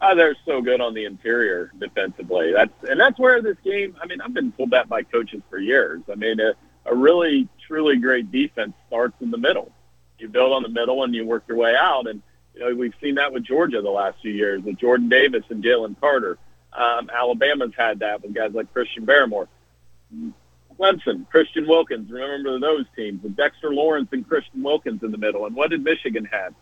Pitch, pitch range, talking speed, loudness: 130 Hz, 110-170 Hz, 210 wpm, -21 LUFS